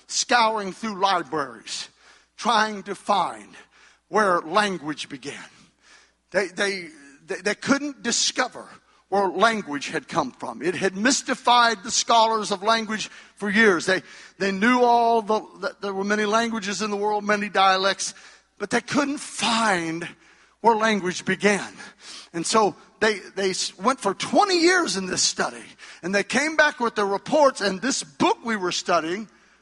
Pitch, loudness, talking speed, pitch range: 210 Hz, -22 LUFS, 150 wpm, 195-230 Hz